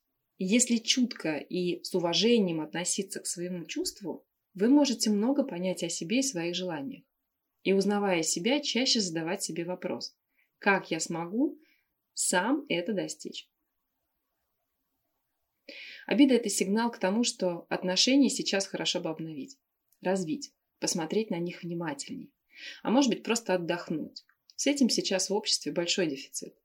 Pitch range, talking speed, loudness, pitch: 175-250 Hz, 135 wpm, -29 LUFS, 200 Hz